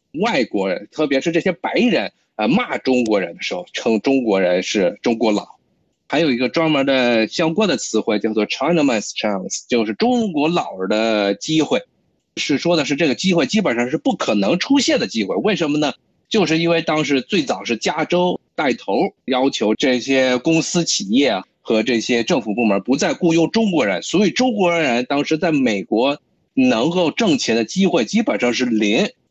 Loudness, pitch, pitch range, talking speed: -18 LUFS, 155 Hz, 125-180 Hz, 290 characters per minute